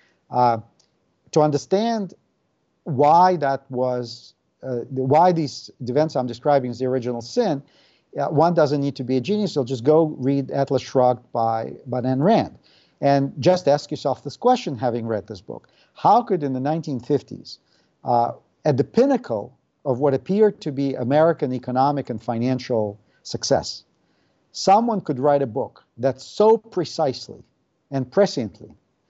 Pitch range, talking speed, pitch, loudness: 125-155 Hz, 145 wpm, 135 Hz, -21 LUFS